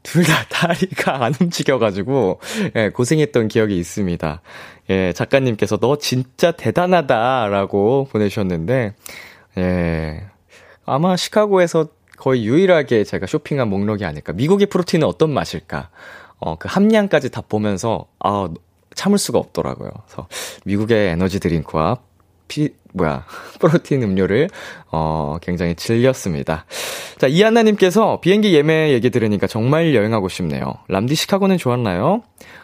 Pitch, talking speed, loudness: 120 Hz, 315 characters per minute, -18 LUFS